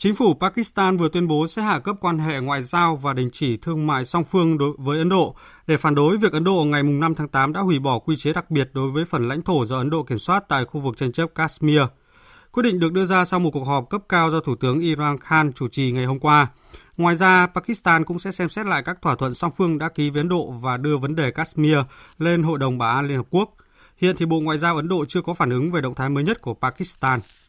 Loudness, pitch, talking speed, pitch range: -21 LUFS, 160 Hz, 275 wpm, 140-175 Hz